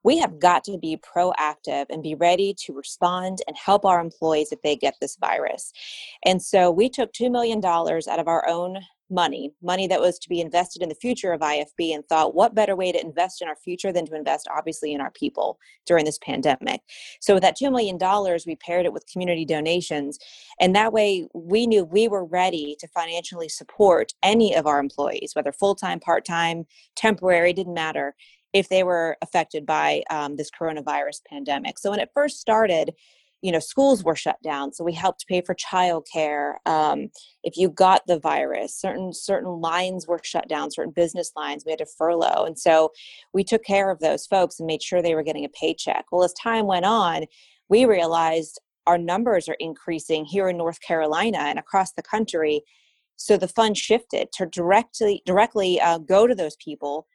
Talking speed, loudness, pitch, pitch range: 195 wpm, -23 LUFS, 175 Hz, 160-195 Hz